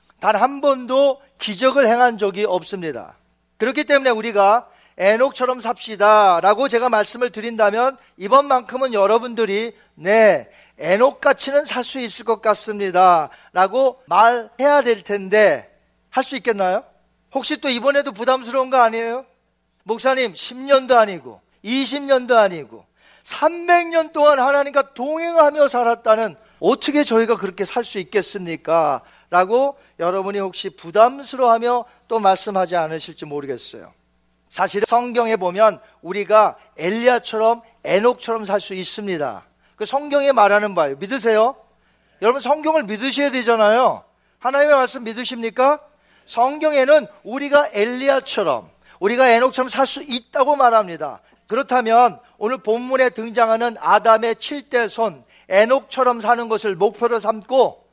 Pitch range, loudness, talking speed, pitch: 205-265 Hz, -18 LUFS, 305 characters per minute, 235 Hz